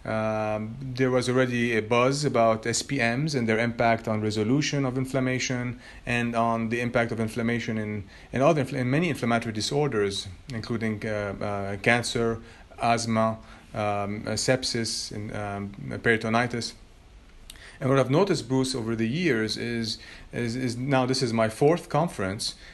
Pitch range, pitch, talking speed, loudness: 110-130 Hz, 115 Hz, 145 wpm, -26 LUFS